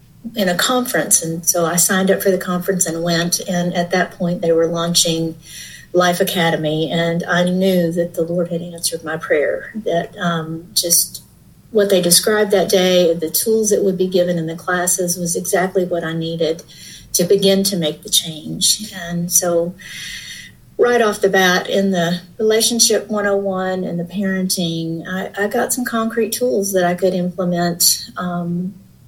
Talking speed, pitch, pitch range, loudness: 175 wpm, 180 Hz, 170-195 Hz, -17 LUFS